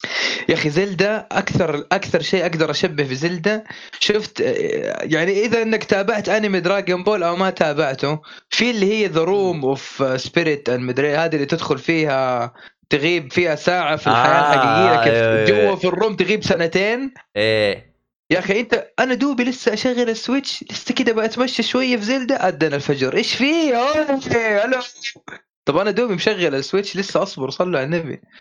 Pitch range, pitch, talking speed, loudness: 160-235 Hz, 195 Hz, 155 wpm, -18 LUFS